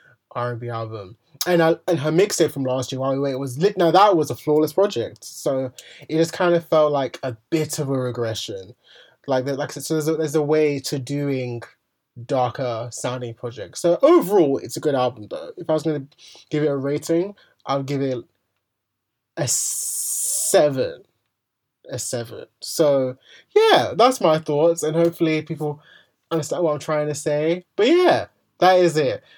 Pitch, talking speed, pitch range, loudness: 150 Hz, 185 wpm, 130-165 Hz, -21 LUFS